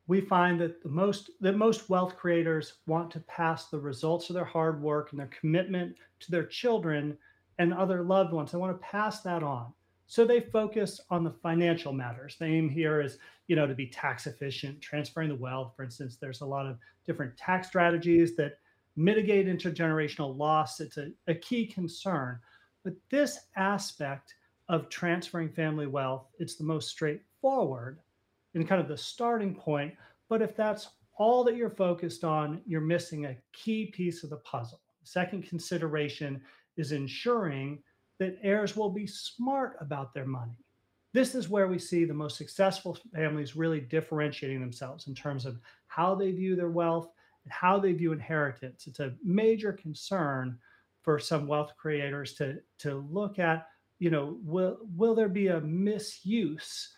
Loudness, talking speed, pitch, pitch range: -31 LUFS, 170 wpm, 165 Hz, 145-185 Hz